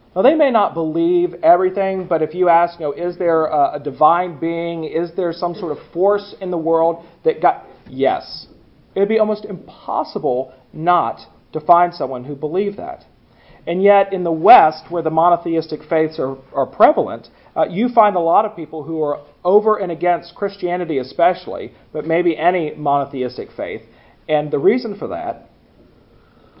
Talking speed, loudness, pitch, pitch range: 175 wpm, -17 LUFS, 170 Hz, 155-185 Hz